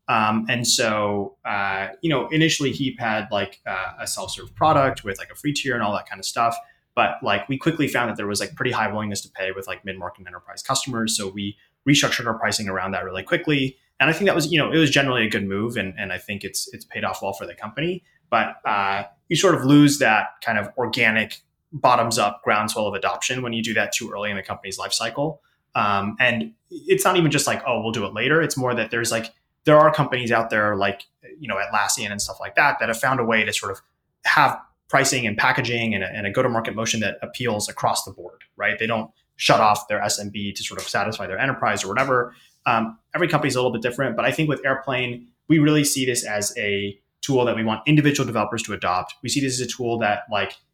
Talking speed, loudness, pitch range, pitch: 240 wpm, -22 LUFS, 100-135 Hz, 115 Hz